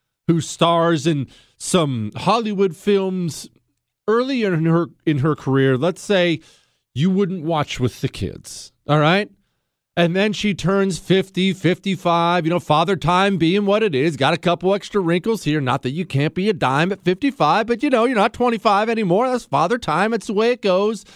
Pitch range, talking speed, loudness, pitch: 155-200 Hz, 185 wpm, -19 LUFS, 175 Hz